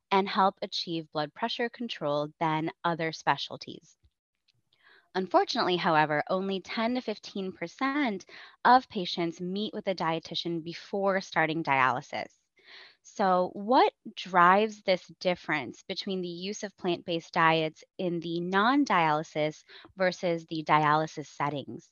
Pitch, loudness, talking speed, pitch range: 180 Hz, -29 LUFS, 115 wpm, 160-200 Hz